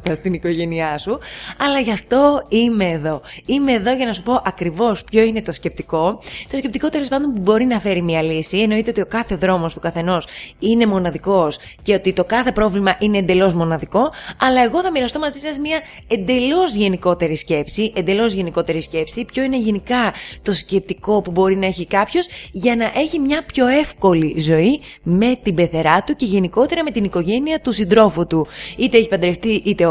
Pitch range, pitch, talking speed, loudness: 175-250 Hz, 205 Hz, 185 wpm, -18 LUFS